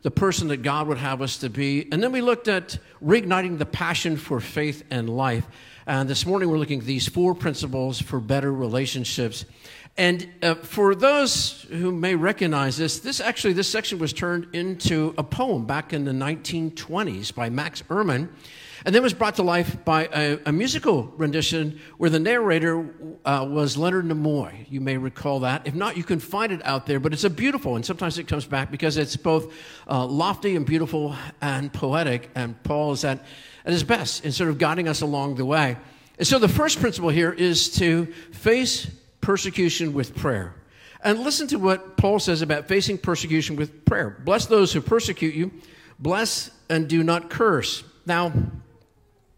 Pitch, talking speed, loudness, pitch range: 155 Hz, 190 wpm, -23 LUFS, 140-175 Hz